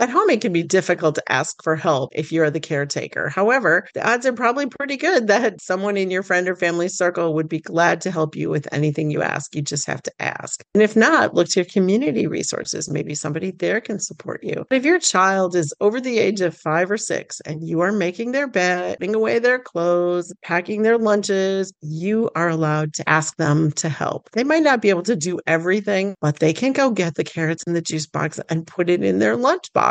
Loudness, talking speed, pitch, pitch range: -20 LUFS, 235 wpm, 180 Hz, 160-215 Hz